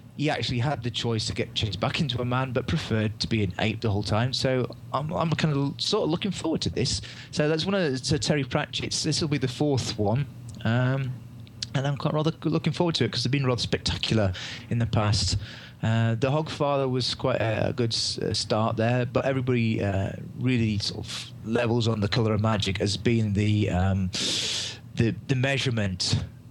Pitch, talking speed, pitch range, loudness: 120 Hz, 210 wpm, 110-135 Hz, -26 LUFS